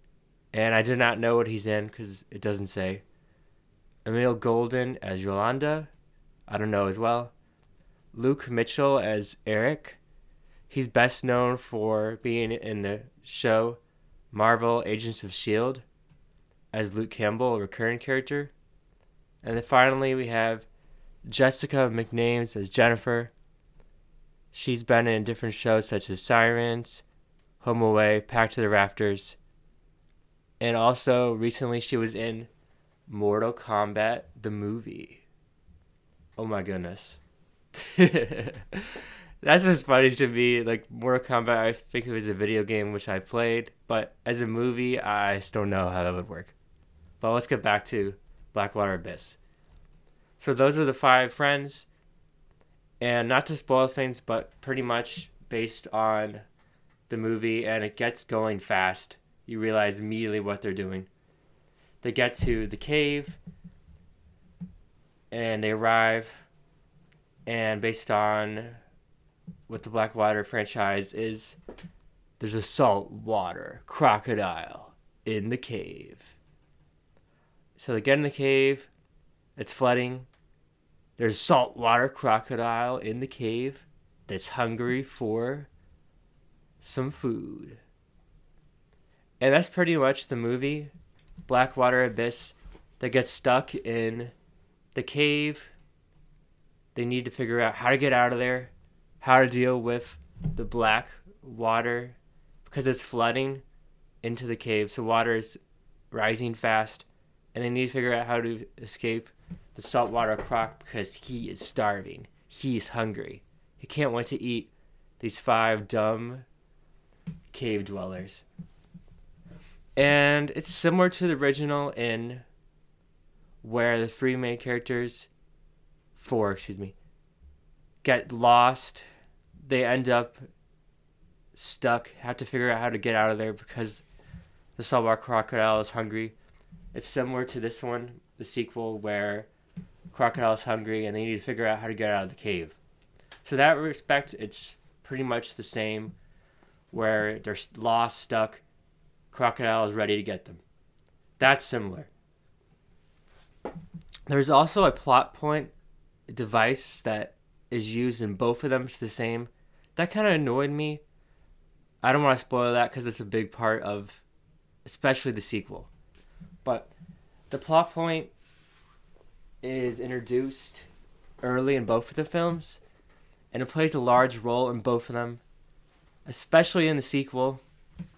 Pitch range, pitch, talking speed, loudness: 105-130 Hz, 115 Hz, 135 wpm, -27 LUFS